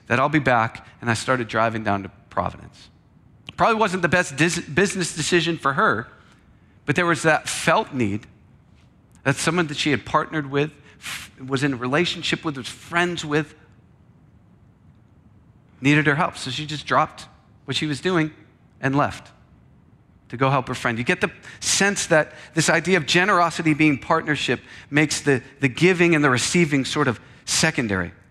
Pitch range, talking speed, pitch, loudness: 125-165 Hz, 170 wpm, 145 Hz, -21 LUFS